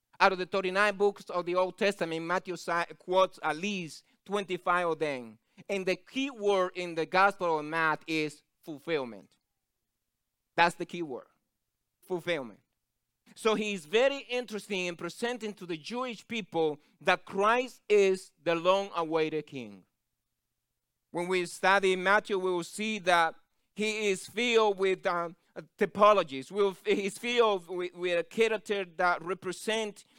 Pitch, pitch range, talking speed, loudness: 185 Hz, 170-205 Hz, 145 wpm, -30 LUFS